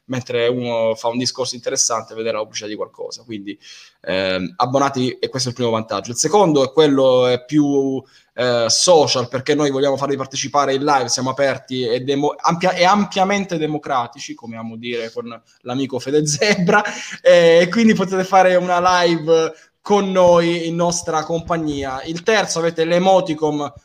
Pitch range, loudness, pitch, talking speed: 125-175 Hz, -17 LUFS, 145 Hz, 160 wpm